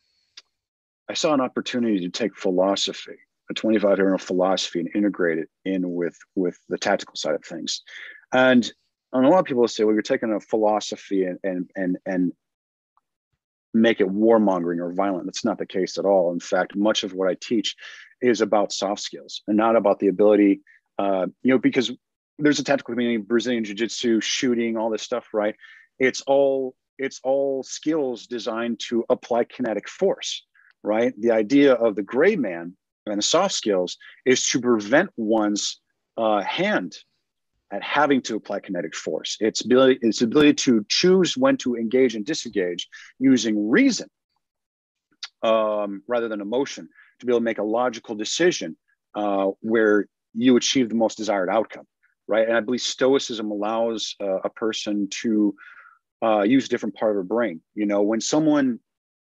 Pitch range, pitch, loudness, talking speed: 100-130 Hz, 115 Hz, -22 LUFS, 170 wpm